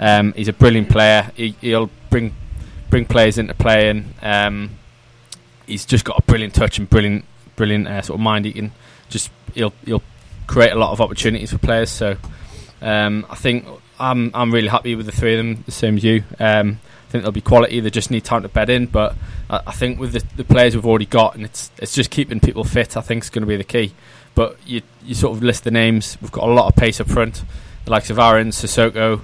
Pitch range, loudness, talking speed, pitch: 105-120 Hz, -17 LUFS, 240 wpm, 110 Hz